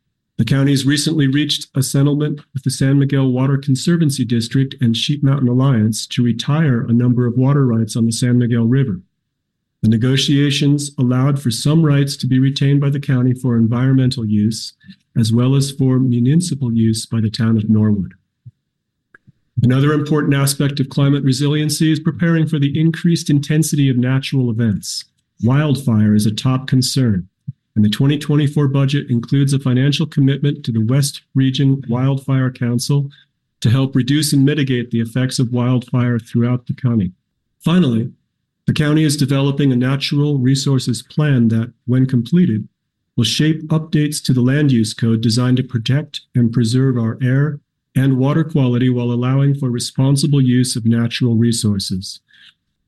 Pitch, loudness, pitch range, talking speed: 130 Hz, -16 LUFS, 120-145 Hz, 160 wpm